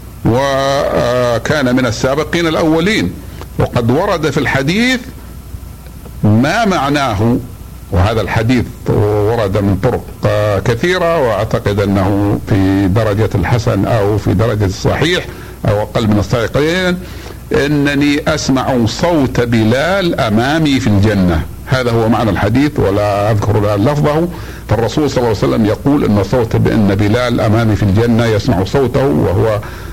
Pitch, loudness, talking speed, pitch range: 115 Hz, -13 LUFS, 120 wpm, 100-135 Hz